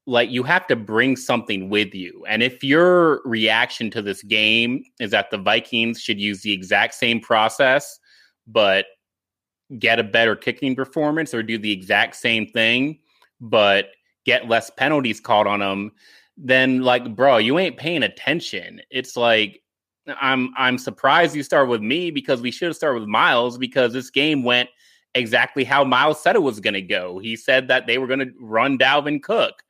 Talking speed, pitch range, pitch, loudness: 180 wpm, 110-140 Hz, 125 Hz, -19 LUFS